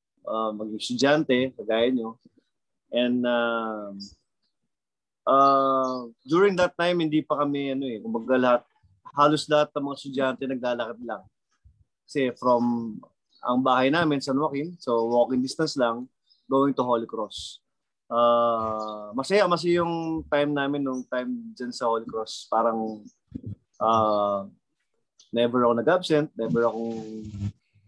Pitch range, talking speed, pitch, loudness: 115-140 Hz, 125 wpm, 125 Hz, -25 LUFS